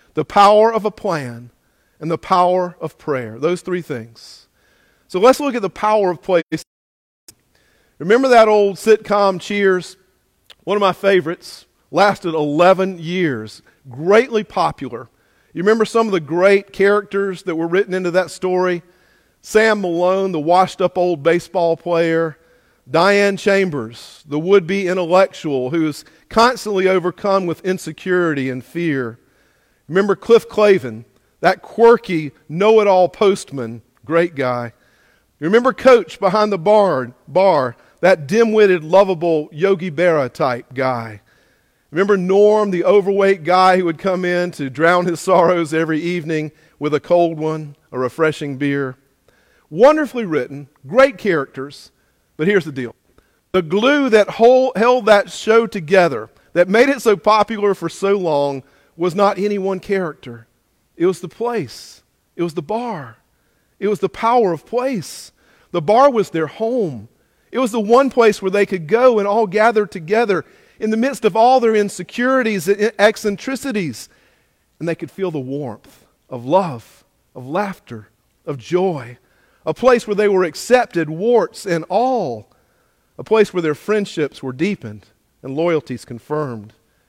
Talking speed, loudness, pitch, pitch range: 150 wpm, -16 LUFS, 180 Hz, 150-205 Hz